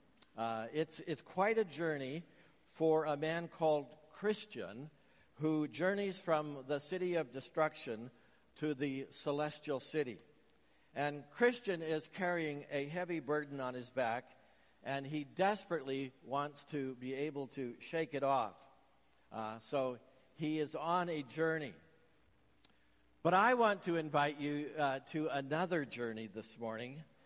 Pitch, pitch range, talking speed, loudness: 150 Hz, 135-160 Hz, 135 wpm, -38 LUFS